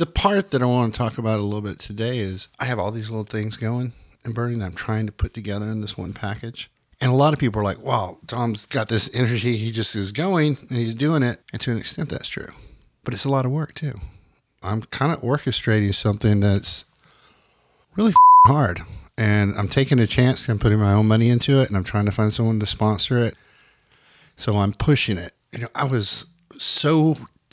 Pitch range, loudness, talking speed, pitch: 105-130 Hz, -21 LUFS, 225 wpm, 115 Hz